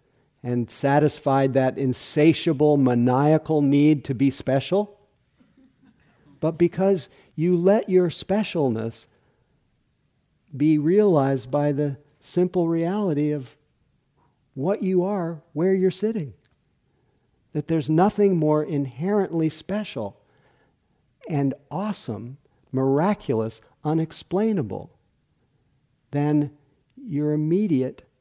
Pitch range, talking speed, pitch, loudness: 135-175 Hz, 85 wpm, 150 Hz, -23 LUFS